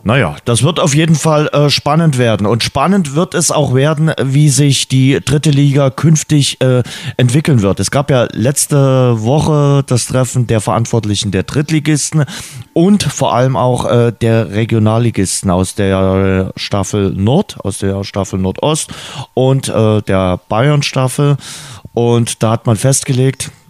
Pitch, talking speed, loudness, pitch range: 130 Hz, 150 wpm, -12 LUFS, 110-145 Hz